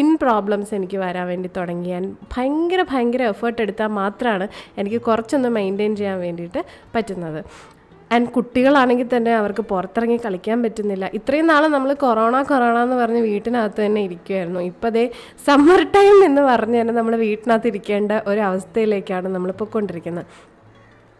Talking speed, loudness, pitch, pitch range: 135 wpm, -19 LUFS, 225 Hz, 195-245 Hz